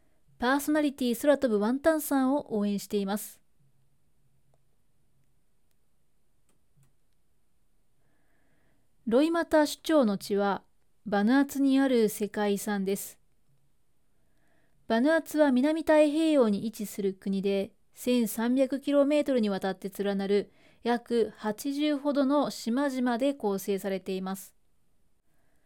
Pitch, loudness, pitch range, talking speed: 230 Hz, -28 LUFS, 200-280 Hz, 215 characters per minute